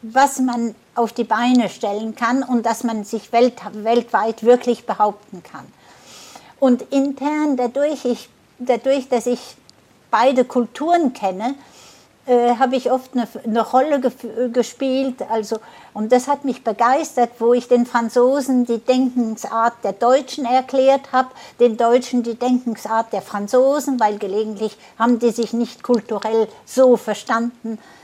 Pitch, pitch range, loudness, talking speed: 240 Hz, 225-255 Hz, -19 LUFS, 140 wpm